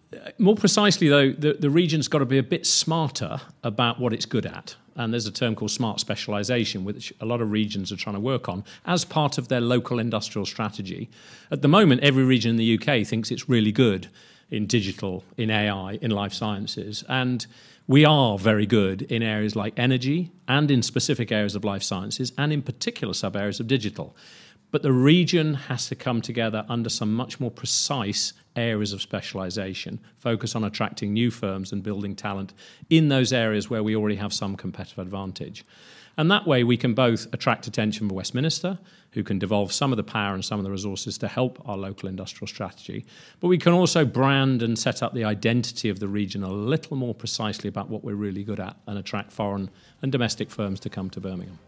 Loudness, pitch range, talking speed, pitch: -24 LUFS, 105-130 Hz, 205 wpm, 115 Hz